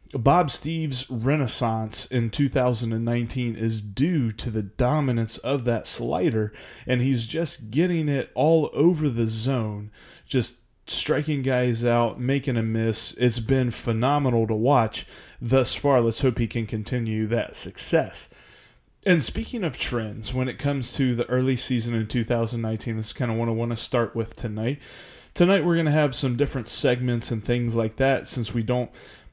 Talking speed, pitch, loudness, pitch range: 170 wpm, 125 Hz, -24 LUFS, 115-135 Hz